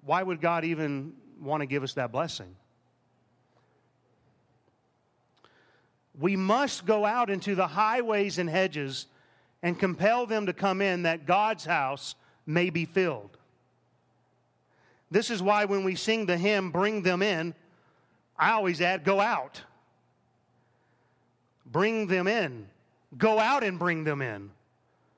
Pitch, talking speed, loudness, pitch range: 175 Hz, 135 wpm, -28 LUFS, 135-200 Hz